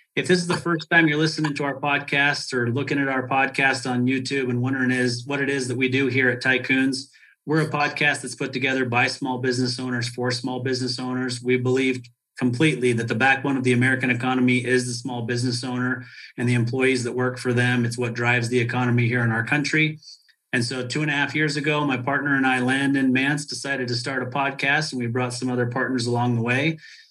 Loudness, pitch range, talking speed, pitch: -22 LUFS, 125-140 Hz, 230 wpm, 130 Hz